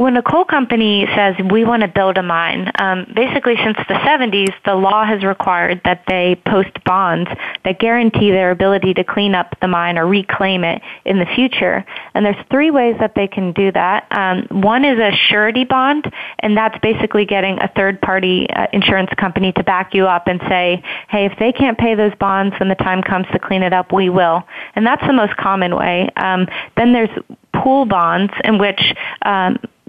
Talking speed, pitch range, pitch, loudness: 205 wpm, 185-220 Hz, 195 Hz, -14 LUFS